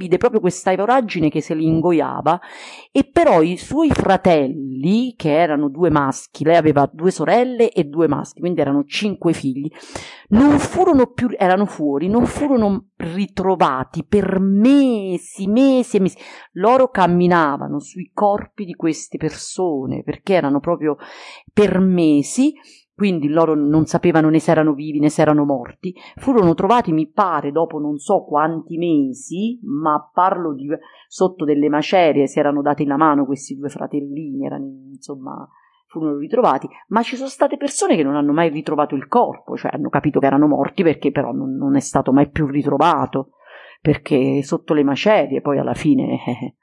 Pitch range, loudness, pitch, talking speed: 150-210 Hz, -17 LUFS, 170 Hz, 160 wpm